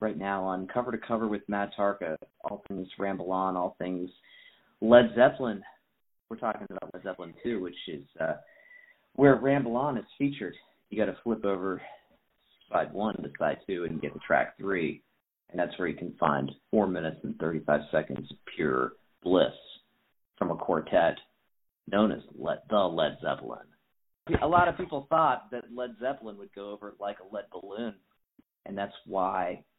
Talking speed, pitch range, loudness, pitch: 175 wpm, 95-125 Hz, -30 LUFS, 105 Hz